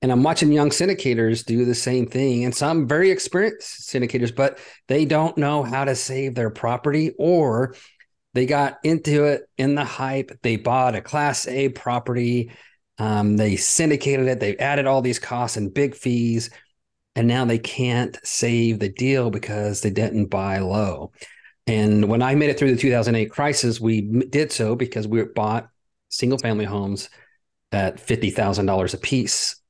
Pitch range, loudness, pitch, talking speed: 115-140 Hz, -21 LUFS, 125 Hz, 170 wpm